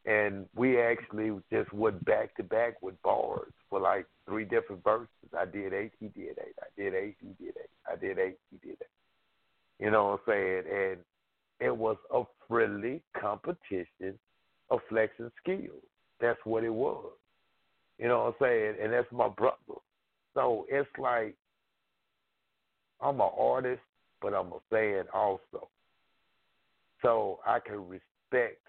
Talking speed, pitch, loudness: 165 wpm, 125 Hz, -32 LUFS